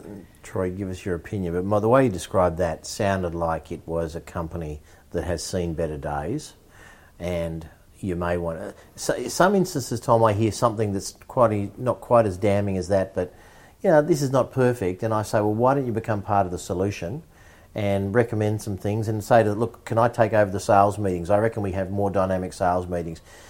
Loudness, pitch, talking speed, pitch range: -24 LUFS, 100 Hz, 220 wpm, 90-110 Hz